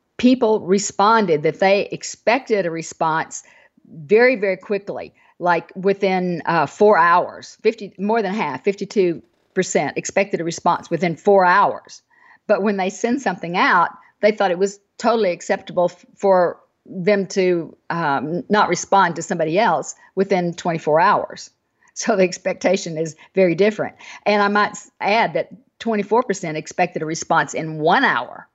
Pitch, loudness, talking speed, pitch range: 195 Hz, -19 LUFS, 145 wpm, 175-210 Hz